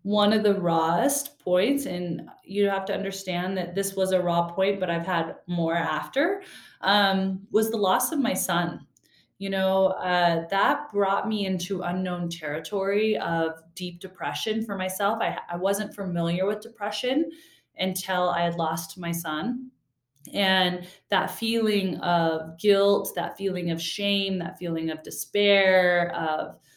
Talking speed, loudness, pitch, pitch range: 150 wpm, -25 LUFS, 190 Hz, 170-200 Hz